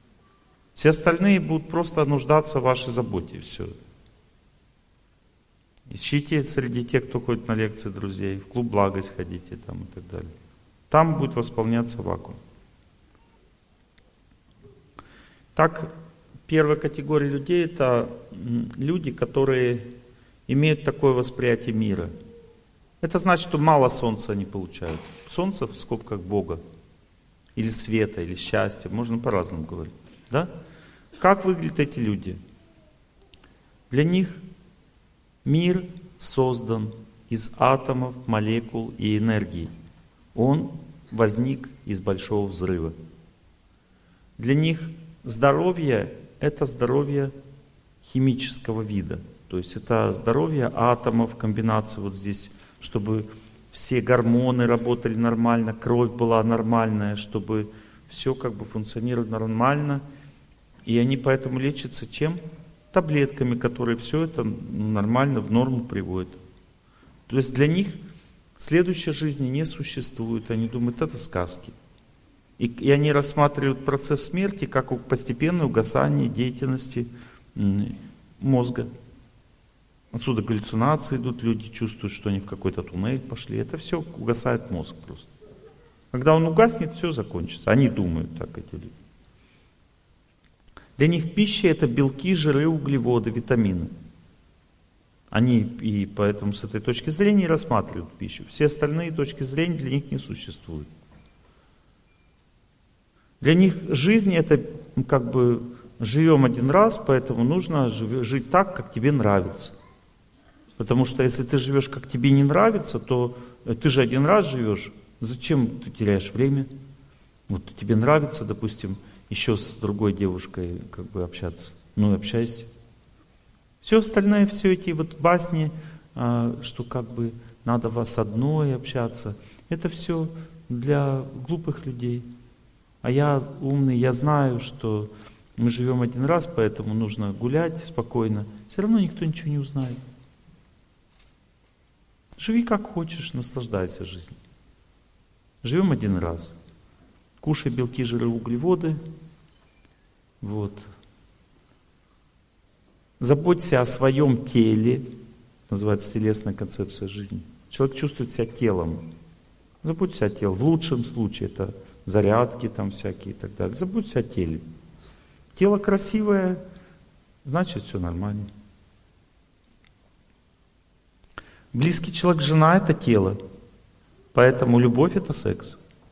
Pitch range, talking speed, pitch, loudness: 105-145 Hz, 115 wpm, 120 Hz, -24 LUFS